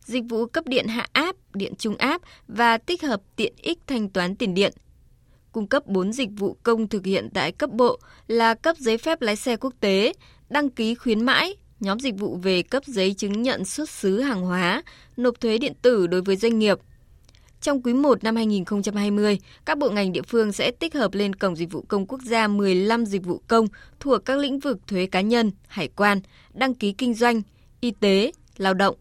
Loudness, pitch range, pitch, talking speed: -23 LUFS, 200-255 Hz, 225 Hz, 210 wpm